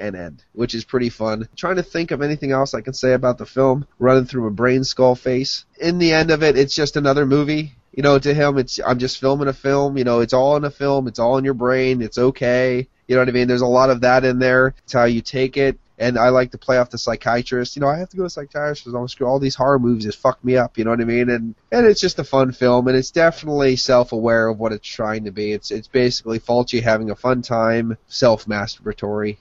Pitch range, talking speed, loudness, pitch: 120-135 Hz, 270 wpm, -18 LUFS, 130 Hz